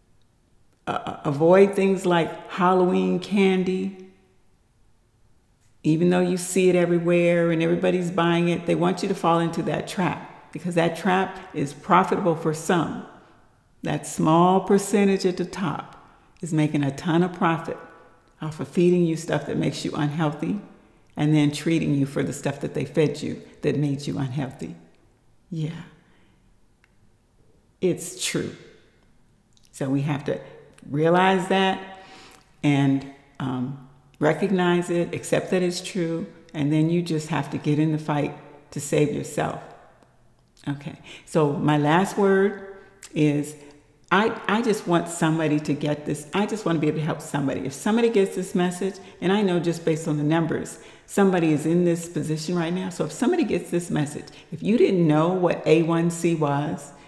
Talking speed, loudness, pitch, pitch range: 160 wpm, -23 LUFS, 165 Hz, 150-180 Hz